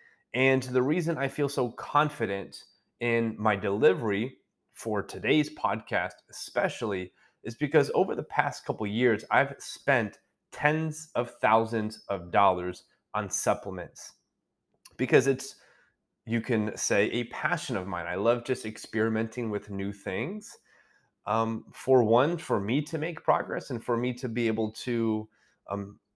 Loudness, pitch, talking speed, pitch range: -28 LUFS, 115 Hz, 145 wpm, 110-135 Hz